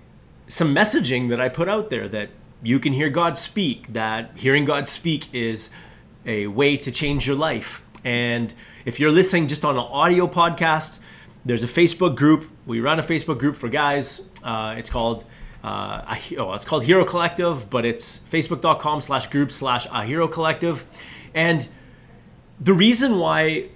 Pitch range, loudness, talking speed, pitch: 125-165 Hz, -20 LUFS, 165 wpm, 145 Hz